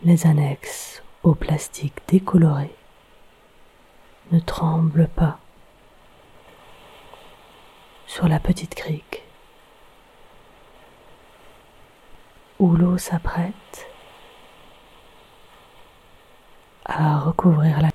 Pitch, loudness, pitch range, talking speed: 165 Hz, -21 LUFS, 155-175 Hz, 60 wpm